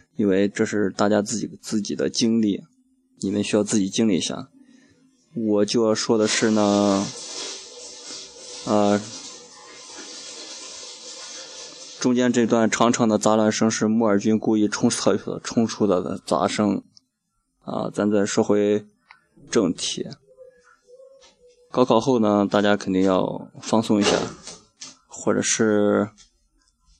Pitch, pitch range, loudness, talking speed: 110 Hz, 105-155 Hz, -21 LUFS, 175 characters per minute